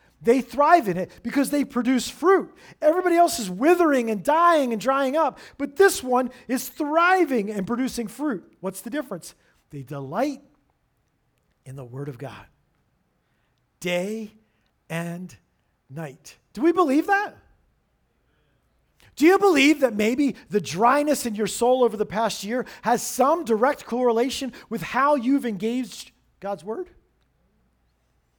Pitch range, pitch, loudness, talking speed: 210-290 Hz, 245 Hz, -22 LUFS, 140 wpm